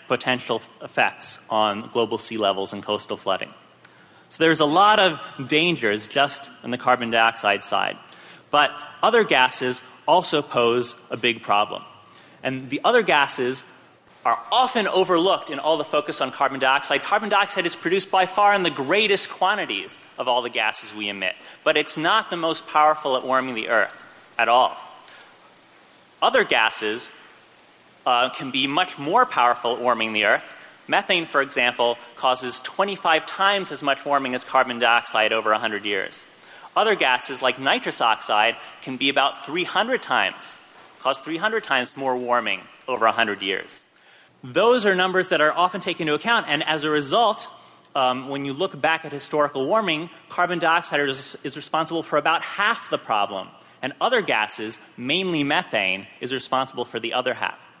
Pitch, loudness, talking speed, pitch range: 140 Hz, -21 LUFS, 165 wpm, 120-165 Hz